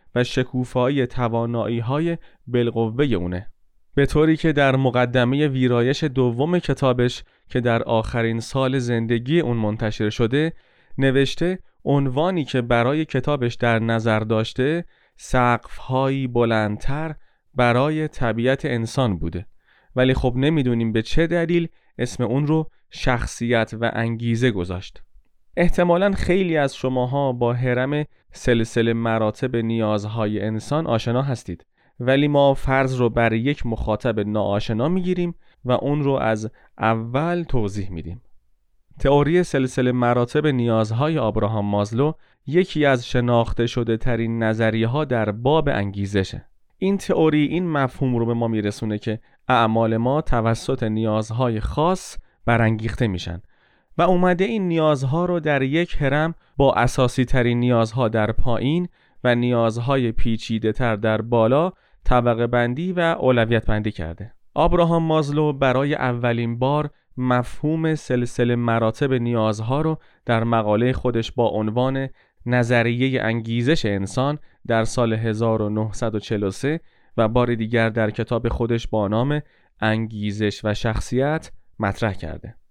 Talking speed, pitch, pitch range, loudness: 120 wpm, 120 Hz, 115-140 Hz, -21 LUFS